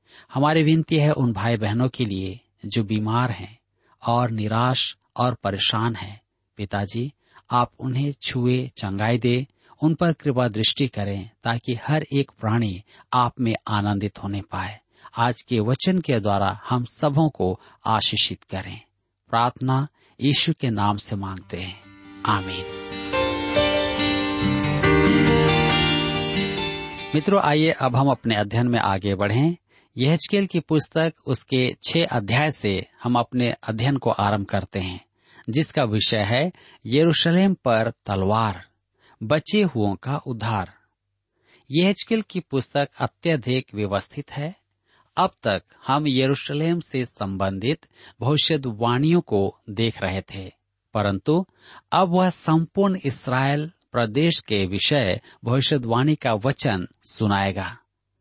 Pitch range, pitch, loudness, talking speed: 100-140 Hz, 115 Hz, -22 LUFS, 120 wpm